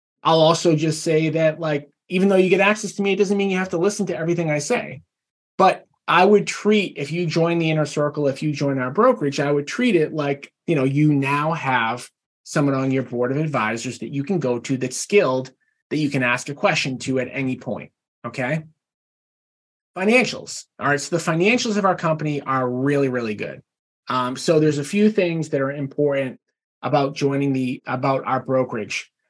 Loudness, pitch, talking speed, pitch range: -21 LUFS, 150 Hz, 205 wpm, 135-170 Hz